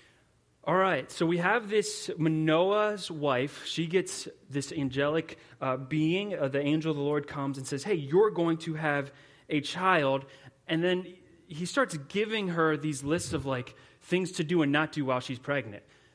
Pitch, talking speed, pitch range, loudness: 155 Hz, 180 wpm, 140-175 Hz, -29 LUFS